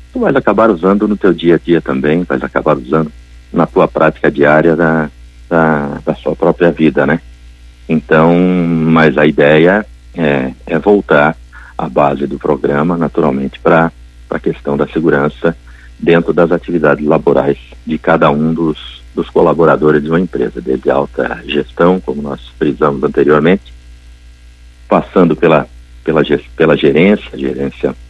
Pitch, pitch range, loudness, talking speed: 75 Hz, 60-85 Hz, -12 LUFS, 145 wpm